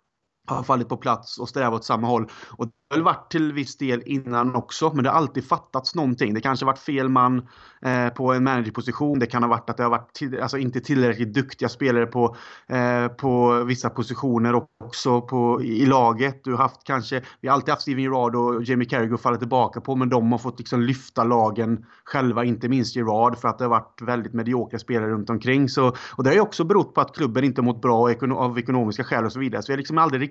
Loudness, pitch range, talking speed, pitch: -22 LUFS, 120-135 Hz, 240 wpm, 125 Hz